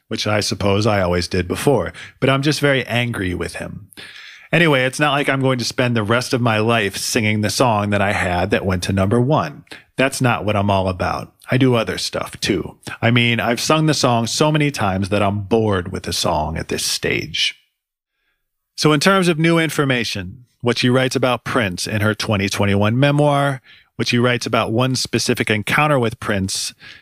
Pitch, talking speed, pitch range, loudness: 115 Hz, 200 wpm, 100-130 Hz, -18 LUFS